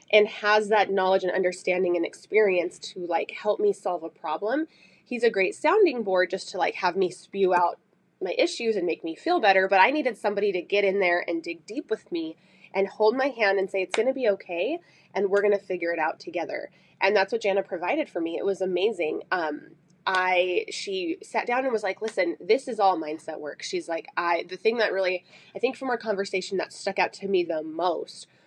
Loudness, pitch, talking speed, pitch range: -26 LUFS, 195 Hz, 230 wpm, 180-220 Hz